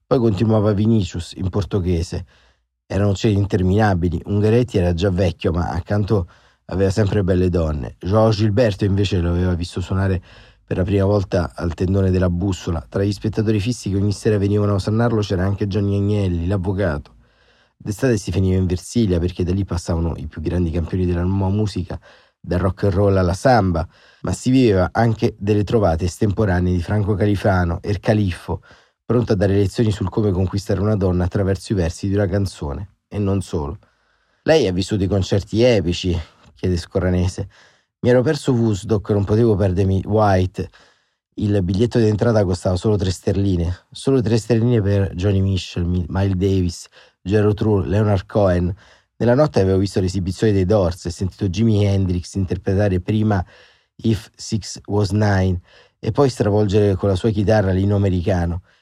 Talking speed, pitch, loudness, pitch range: 165 wpm, 100 Hz, -19 LUFS, 90-105 Hz